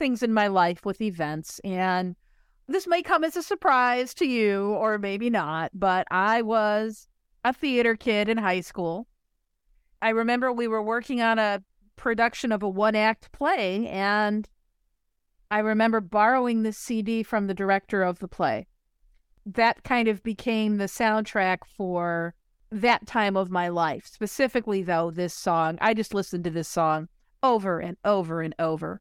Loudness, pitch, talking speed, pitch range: -25 LUFS, 210 Hz, 165 wpm, 185-230 Hz